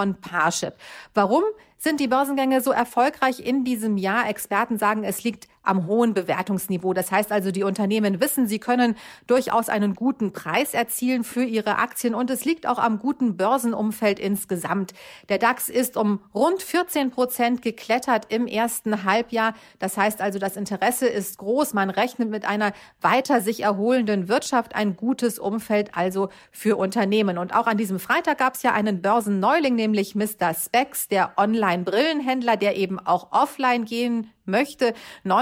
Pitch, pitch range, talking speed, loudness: 225 Hz, 200-250 Hz, 160 wpm, -23 LUFS